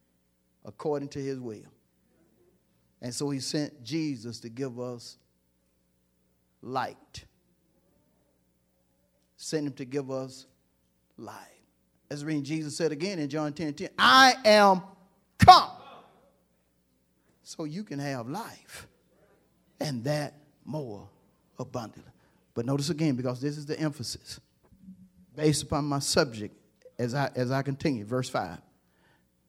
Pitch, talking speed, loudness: 130 Hz, 120 wpm, -27 LUFS